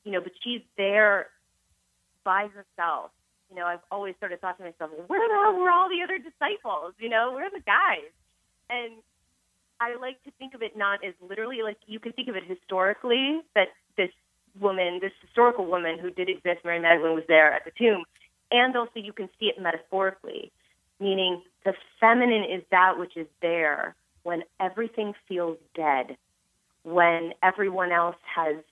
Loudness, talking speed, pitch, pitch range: -26 LUFS, 180 wpm, 195 Hz, 175-230 Hz